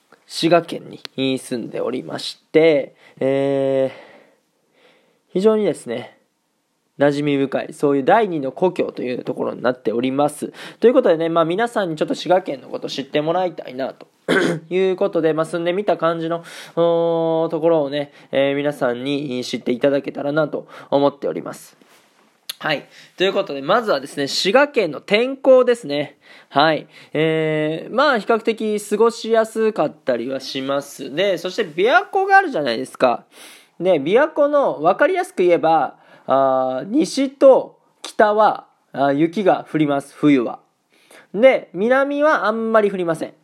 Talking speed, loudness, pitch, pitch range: 315 characters per minute, -19 LUFS, 165 Hz, 140-220 Hz